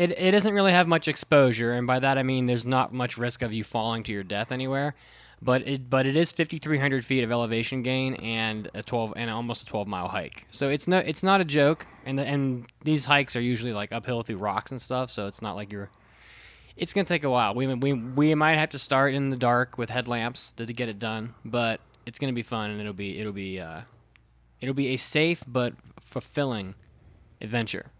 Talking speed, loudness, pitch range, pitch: 230 wpm, -26 LUFS, 115-140 Hz, 125 Hz